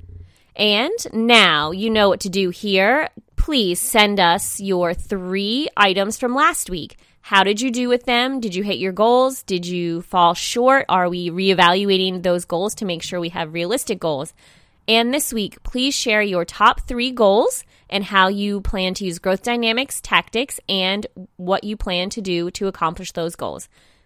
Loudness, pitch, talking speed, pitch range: -18 LUFS, 195 Hz, 180 wpm, 180-225 Hz